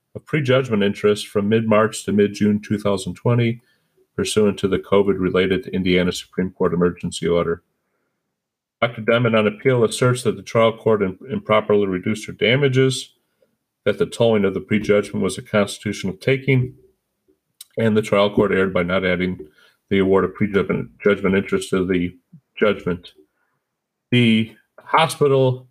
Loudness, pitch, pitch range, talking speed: -19 LUFS, 105 Hz, 95-125 Hz, 145 wpm